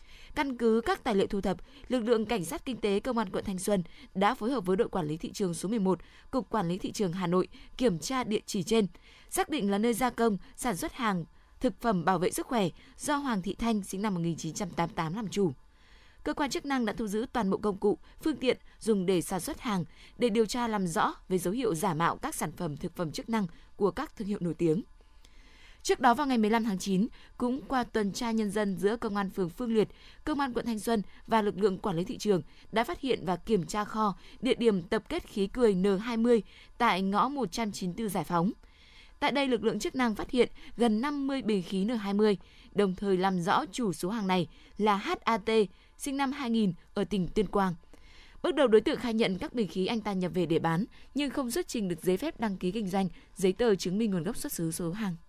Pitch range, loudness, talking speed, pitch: 190-245 Hz, -30 LUFS, 240 wpm, 215 Hz